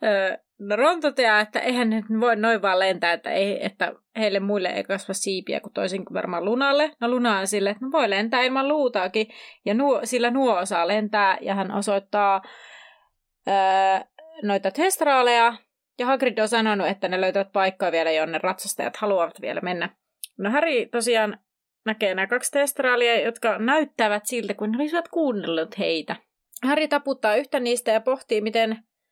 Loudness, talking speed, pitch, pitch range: -23 LUFS, 160 wpm, 220 Hz, 195-255 Hz